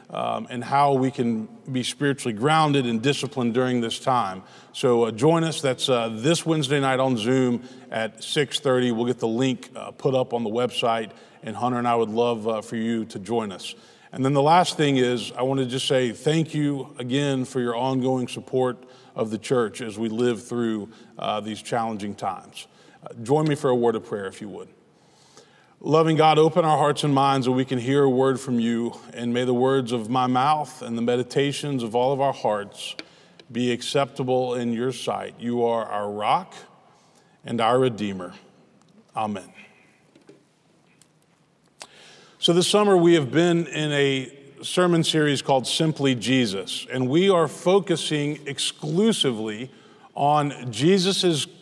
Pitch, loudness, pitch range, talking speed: 130 Hz, -23 LUFS, 120-145 Hz, 175 wpm